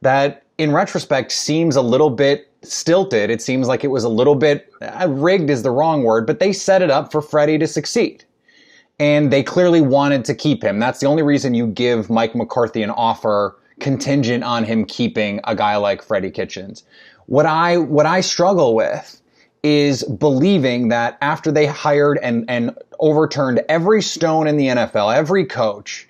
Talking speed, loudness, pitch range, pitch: 180 wpm, -17 LUFS, 125-155 Hz, 145 Hz